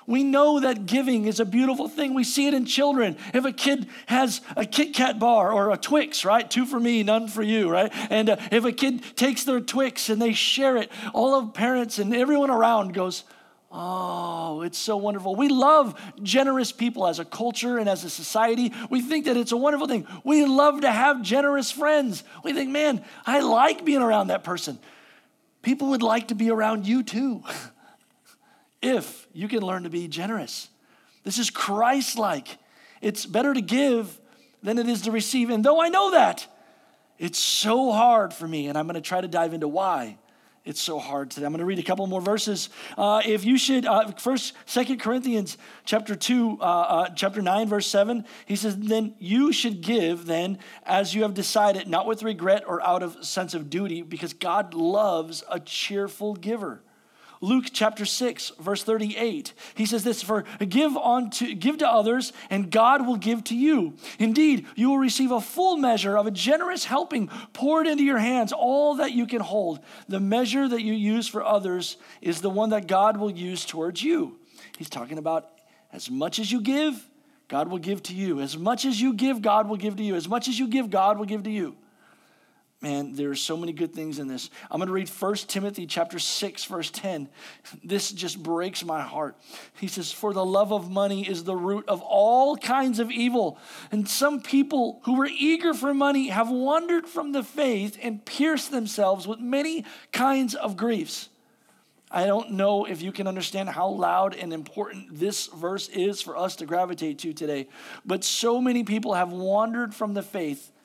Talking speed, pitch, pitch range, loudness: 200 wpm, 220 Hz, 195-255 Hz, -24 LUFS